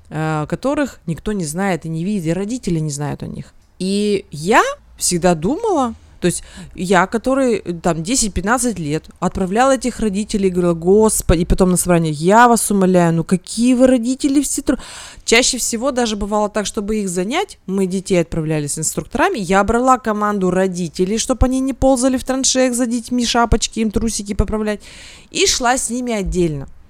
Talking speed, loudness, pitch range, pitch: 170 wpm, -17 LUFS, 180-245 Hz, 210 Hz